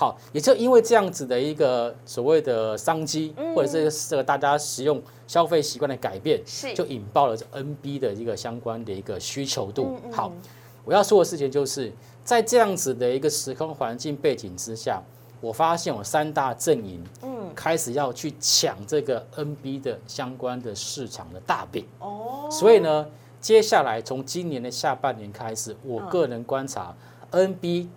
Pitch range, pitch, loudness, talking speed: 120-170 Hz, 140 Hz, -24 LUFS, 270 characters per minute